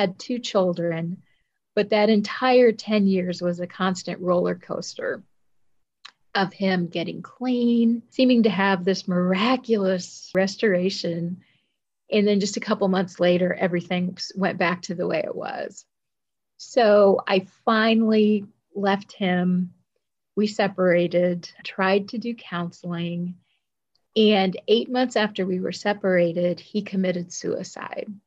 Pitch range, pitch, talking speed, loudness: 180-215 Hz, 195 Hz, 125 wpm, -23 LUFS